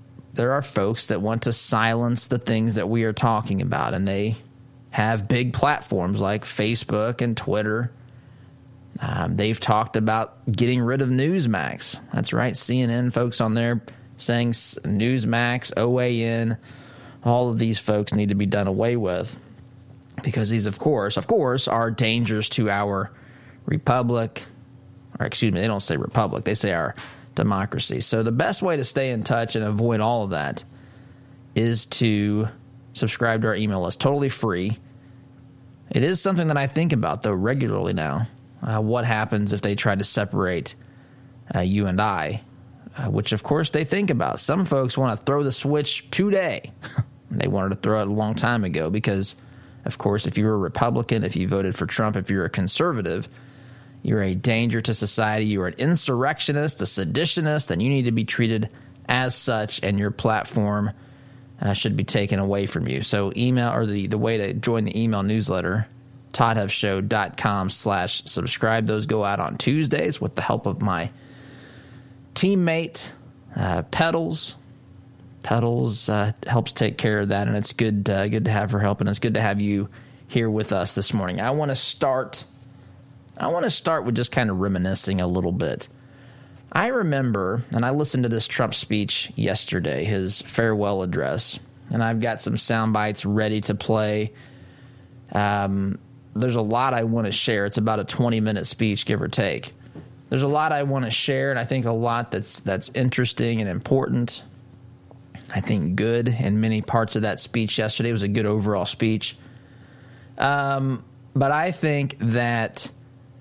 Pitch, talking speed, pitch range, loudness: 115 Hz, 175 wpm, 105-130 Hz, -23 LUFS